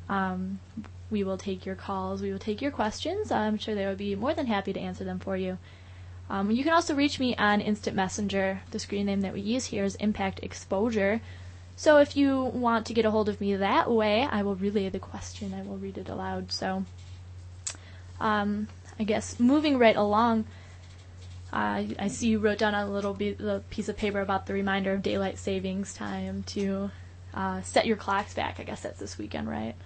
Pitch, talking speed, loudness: 195 Hz, 205 wpm, -29 LUFS